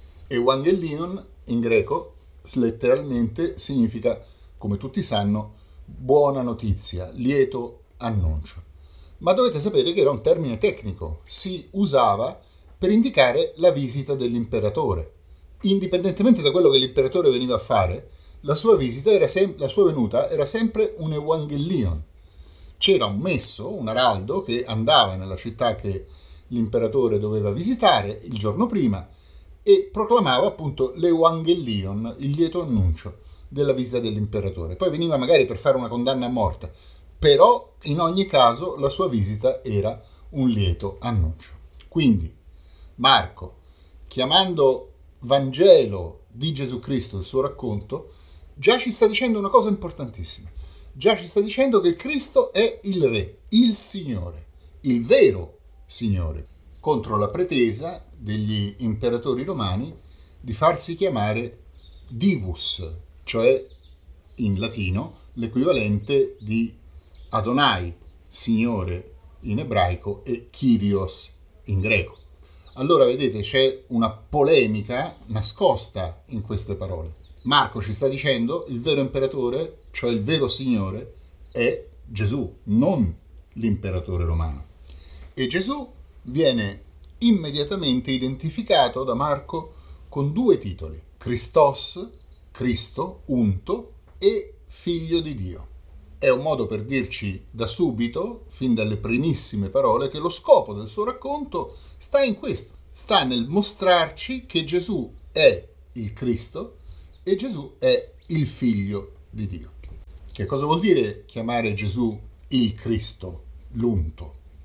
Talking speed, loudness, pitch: 120 wpm, -20 LUFS, 115 Hz